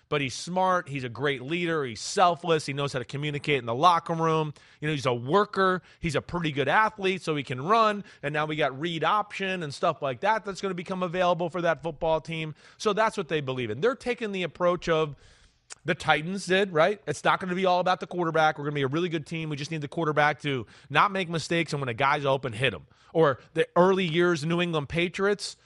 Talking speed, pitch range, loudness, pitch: 250 wpm, 145-180 Hz, -26 LUFS, 165 Hz